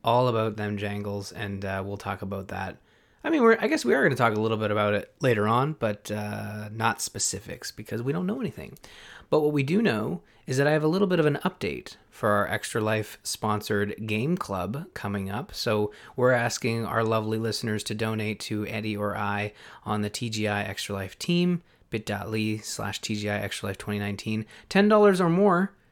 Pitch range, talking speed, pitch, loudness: 105-125 Hz, 200 wpm, 110 Hz, -27 LUFS